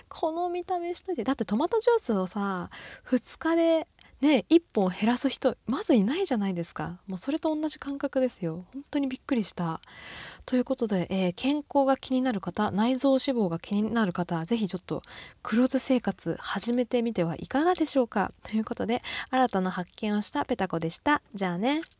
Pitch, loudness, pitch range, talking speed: 245 Hz, -27 LUFS, 195-280 Hz, 375 characters per minute